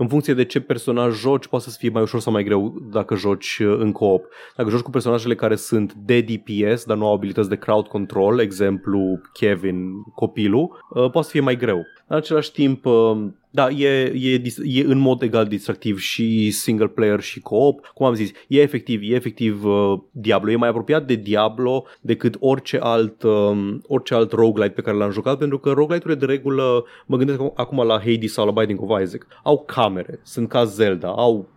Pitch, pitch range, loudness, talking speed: 115 Hz, 105-130 Hz, -20 LUFS, 195 wpm